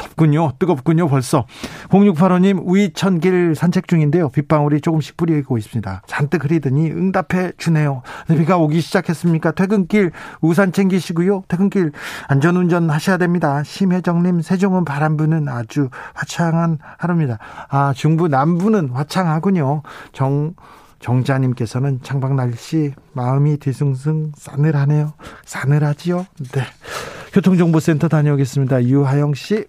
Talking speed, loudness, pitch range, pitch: 315 characters per minute, -17 LUFS, 145-180 Hz, 160 Hz